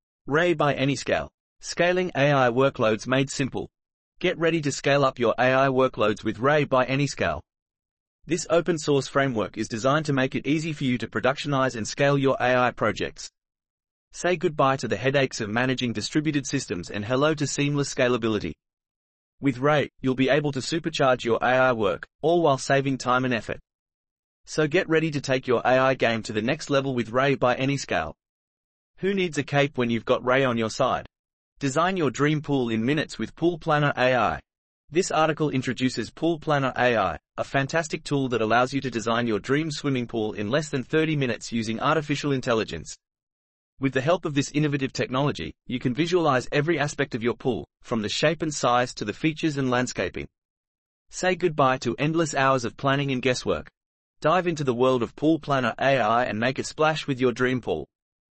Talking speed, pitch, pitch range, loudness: 185 wpm, 135 Hz, 125-150 Hz, -24 LUFS